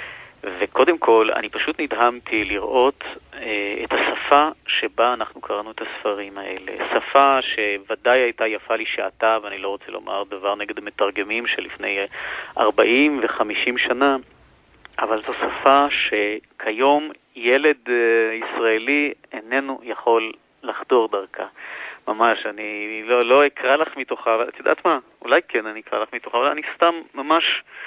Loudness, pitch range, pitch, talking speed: -20 LUFS, 105-135 Hz, 115 Hz, 135 wpm